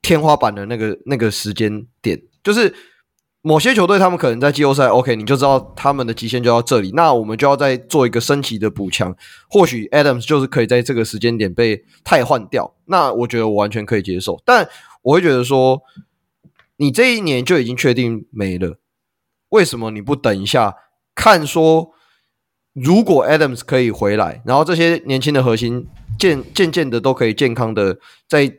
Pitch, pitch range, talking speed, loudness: 125 Hz, 115-145 Hz, 300 characters per minute, -15 LUFS